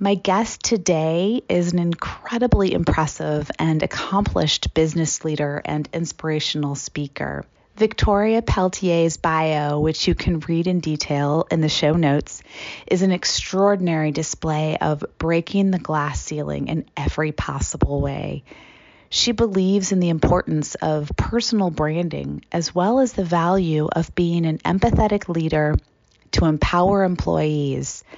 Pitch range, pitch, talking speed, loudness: 150-190 Hz, 165 Hz, 130 wpm, -21 LUFS